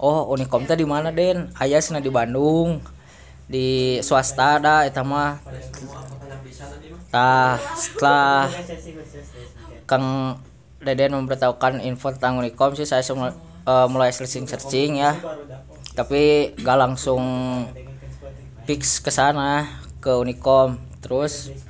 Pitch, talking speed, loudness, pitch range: 130 Hz, 100 wpm, -20 LUFS, 125-145 Hz